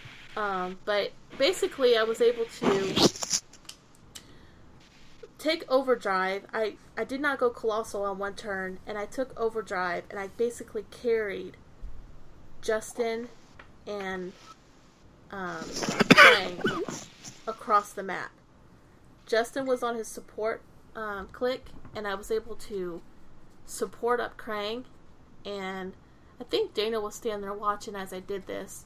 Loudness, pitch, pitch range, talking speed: -28 LUFS, 220 Hz, 200-245 Hz, 125 wpm